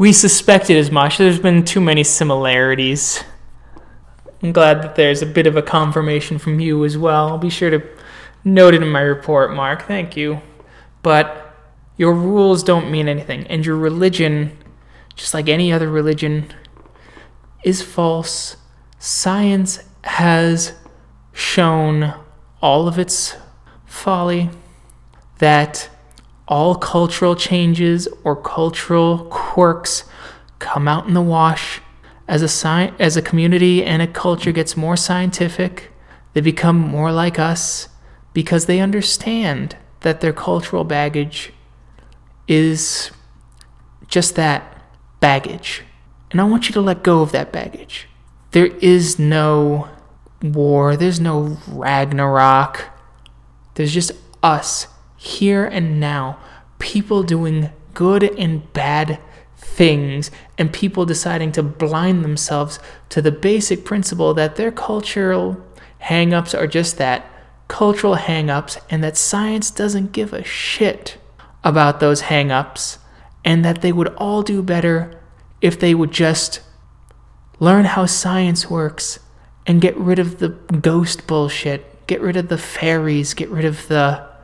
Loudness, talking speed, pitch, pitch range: -16 LUFS, 130 wpm, 160 Hz, 150-180 Hz